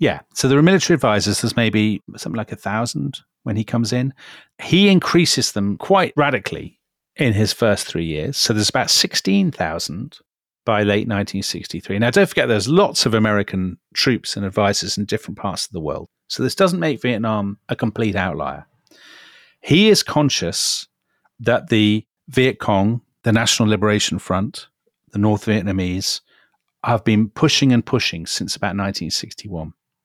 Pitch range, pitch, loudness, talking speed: 100-130 Hz, 110 Hz, -18 LUFS, 170 wpm